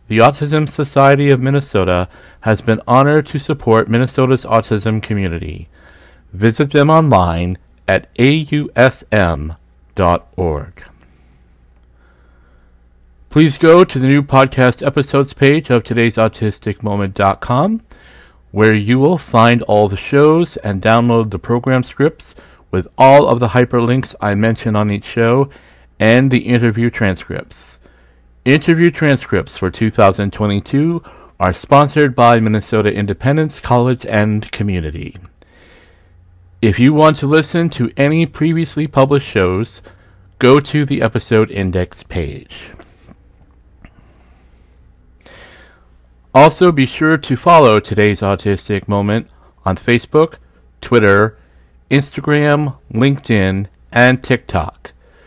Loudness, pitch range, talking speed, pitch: -13 LUFS, 90-135 Hz, 105 wpm, 110 Hz